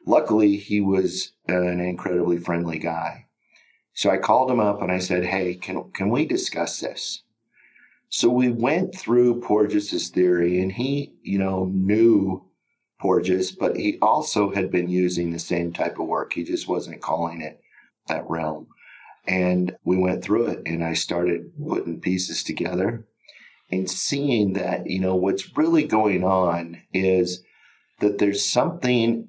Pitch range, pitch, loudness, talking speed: 90-105 Hz, 95 Hz, -23 LUFS, 155 wpm